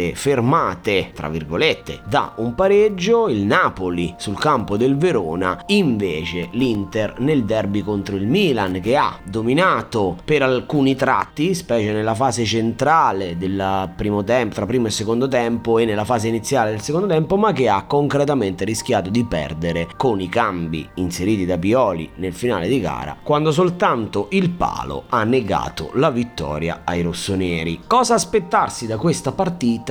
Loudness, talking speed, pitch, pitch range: -19 LUFS, 150 wpm, 115 Hz, 95-135 Hz